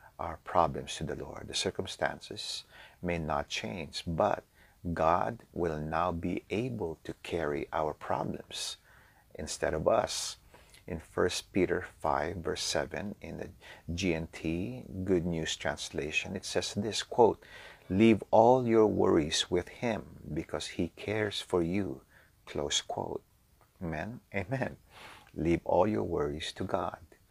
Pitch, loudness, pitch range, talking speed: 90 Hz, -32 LUFS, 80-105 Hz, 130 wpm